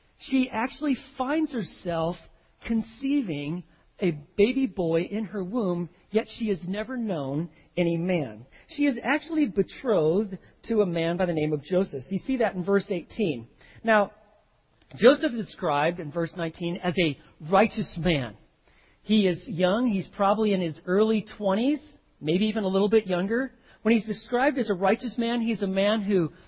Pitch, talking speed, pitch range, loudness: 195 Hz, 165 wpm, 170-225 Hz, -26 LUFS